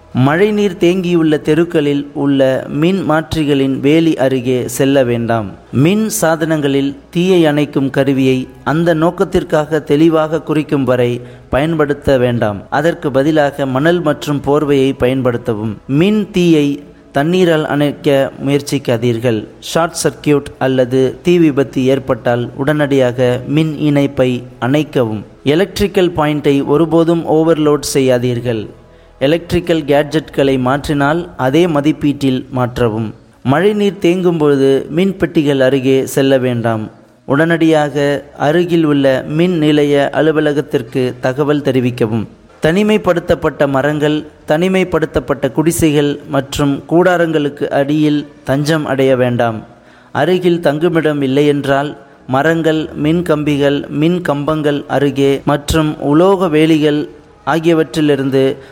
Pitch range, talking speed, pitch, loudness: 135-160 Hz, 95 wpm, 145 Hz, -13 LUFS